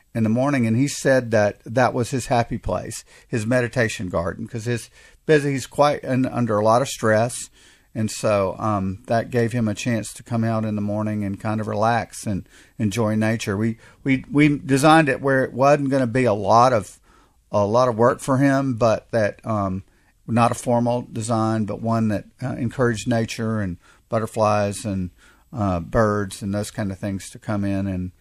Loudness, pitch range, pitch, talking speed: -21 LUFS, 105-125 Hz, 115 Hz, 200 wpm